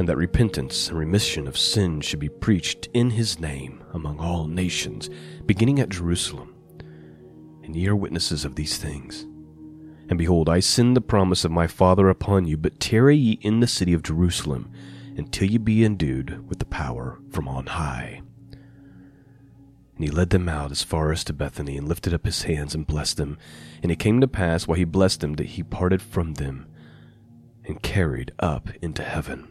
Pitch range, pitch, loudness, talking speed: 75-100 Hz, 85 Hz, -23 LUFS, 185 wpm